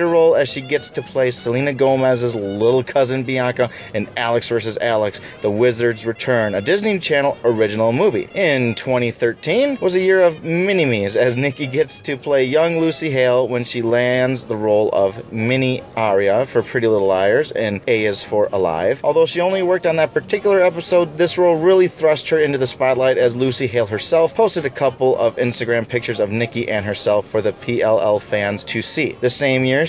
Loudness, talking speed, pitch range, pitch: -17 LUFS, 190 wpm, 120-160 Hz, 130 Hz